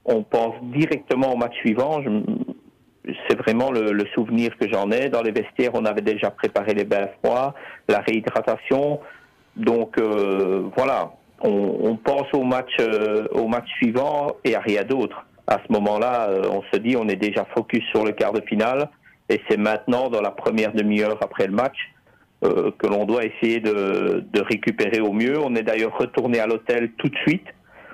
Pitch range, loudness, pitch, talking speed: 105-125 Hz, -22 LUFS, 115 Hz, 185 wpm